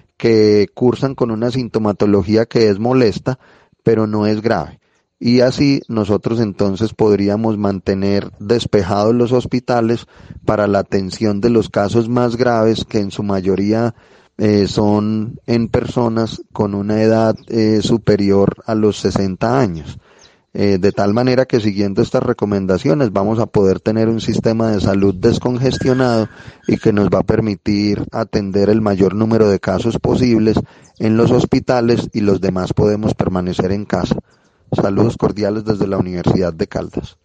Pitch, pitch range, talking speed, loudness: 110 Hz, 100-115 Hz, 150 wpm, -16 LUFS